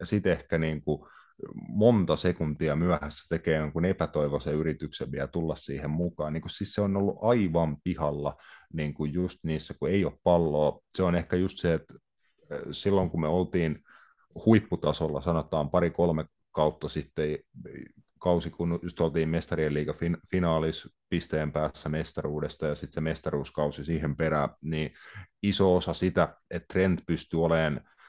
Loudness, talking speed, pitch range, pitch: -29 LUFS, 145 wpm, 75-90 Hz, 80 Hz